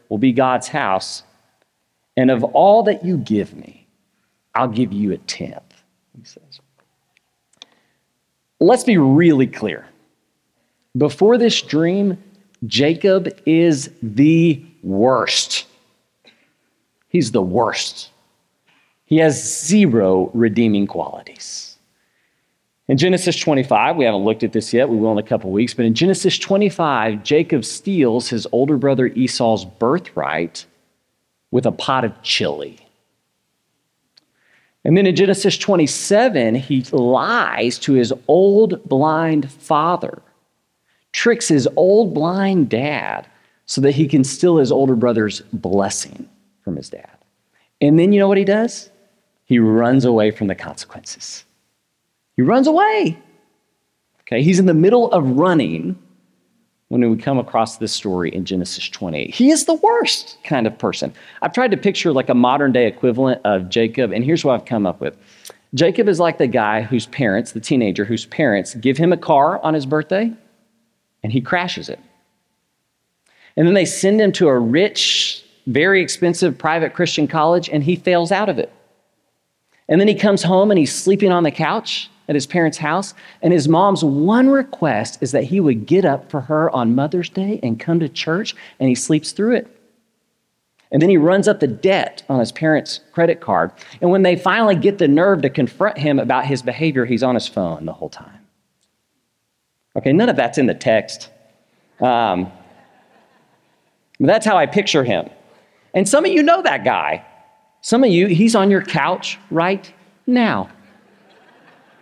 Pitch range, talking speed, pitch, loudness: 125-195 Hz, 160 wpm, 155 Hz, -16 LUFS